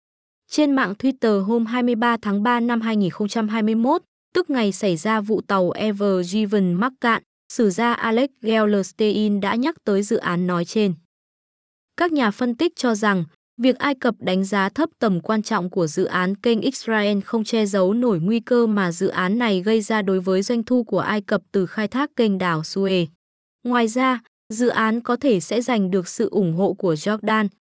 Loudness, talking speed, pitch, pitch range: -21 LUFS, 195 wpm, 215 Hz, 195-240 Hz